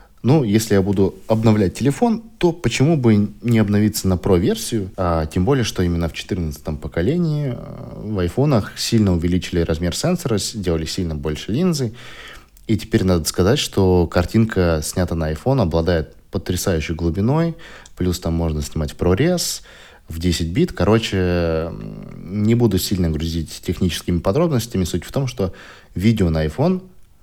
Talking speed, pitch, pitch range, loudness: 145 wpm, 95 Hz, 85-115 Hz, -19 LUFS